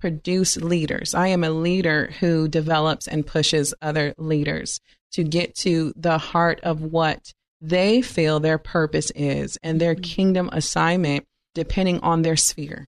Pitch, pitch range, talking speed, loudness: 165 Hz, 155-175 Hz, 150 wpm, -21 LUFS